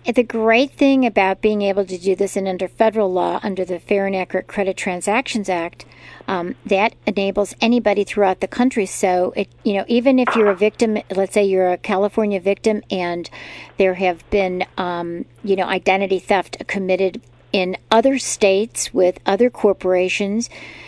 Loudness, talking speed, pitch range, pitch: -18 LUFS, 170 wpm, 185-215 Hz, 195 Hz